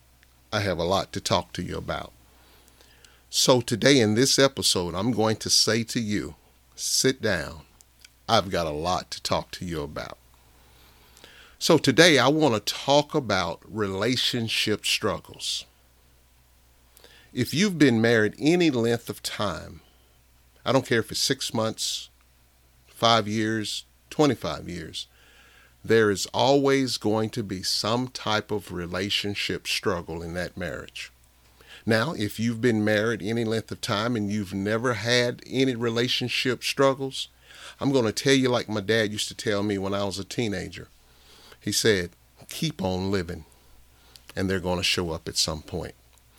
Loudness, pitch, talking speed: -24 LUFS, 100 Hz, 155 wpm